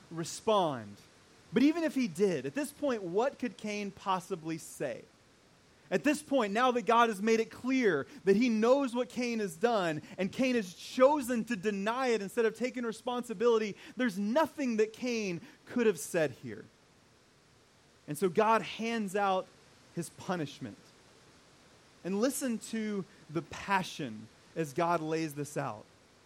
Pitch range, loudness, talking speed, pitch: 180-245 Hz, -32 LUFS, 155 wpm, 220 Hz